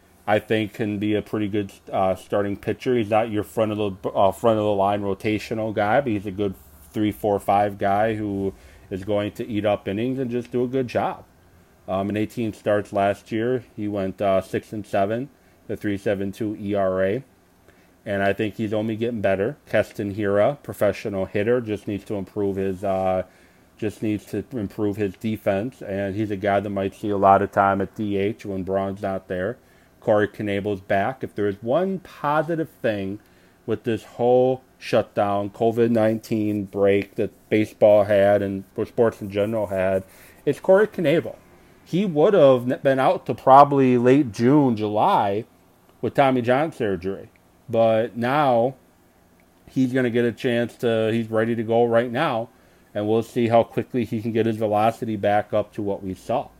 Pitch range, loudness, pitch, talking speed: 100-115 Hz, -22 LUFS, 105 Hz, 180 wpm